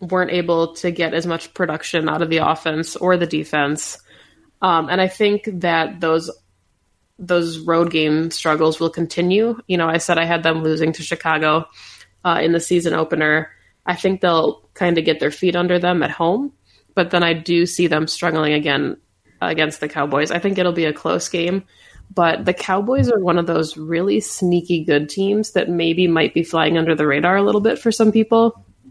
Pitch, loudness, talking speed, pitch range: 165 Hz, -18 LUFS, 200 wpm, 155-180 Hz